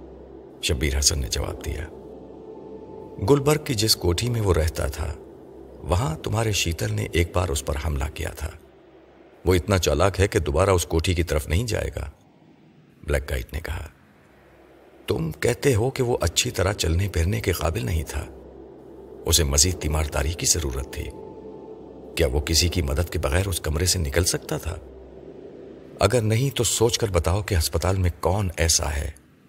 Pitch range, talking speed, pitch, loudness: 80-100 Hz, 175 wpm, 85 Hz, -23 LUFS